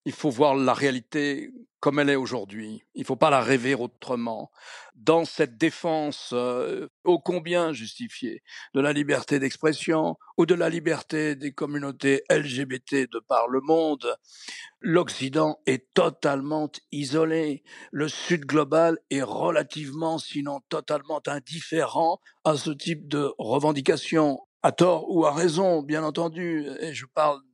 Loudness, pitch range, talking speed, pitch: -25 LUFS, 140-165 Hz, 140 wpm, 150 Hz